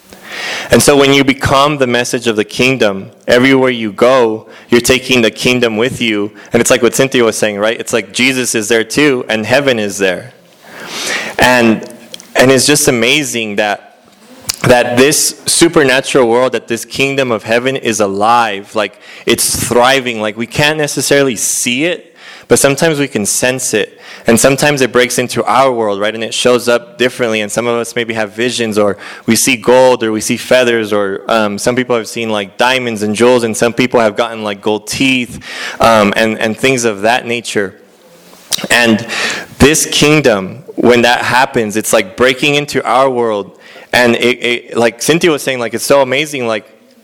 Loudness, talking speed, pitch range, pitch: -11 LUFS, 185 wpm, 110-130 Hz, 120 Hz